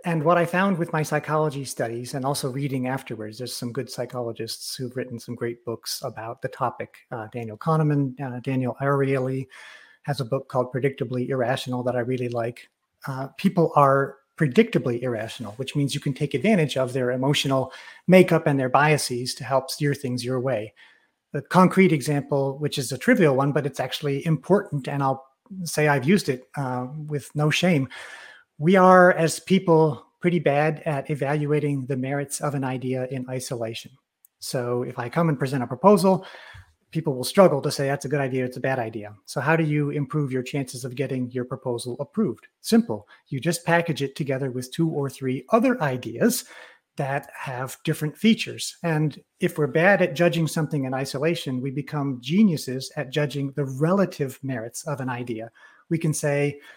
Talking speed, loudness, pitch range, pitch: 185 wpm, -24 LUFS, 130-155 Hz, 140 Hz